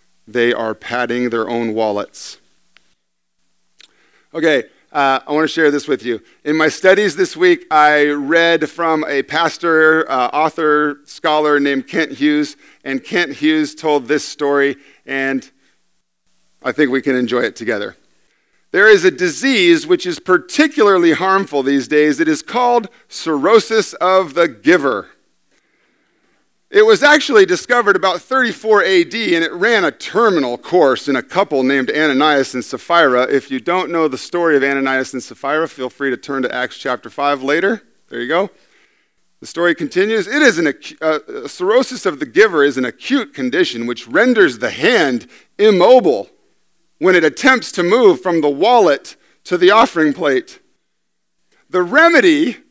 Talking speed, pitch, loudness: 160 wpm, 155 Hz, -14 LUFS